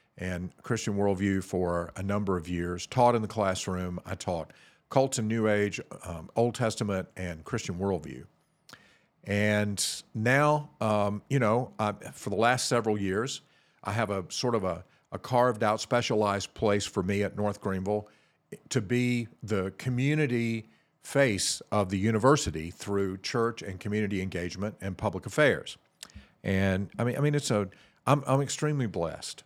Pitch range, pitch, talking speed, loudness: 95-120 Hz, 105 Hz, 155 wpm, -29 LUFS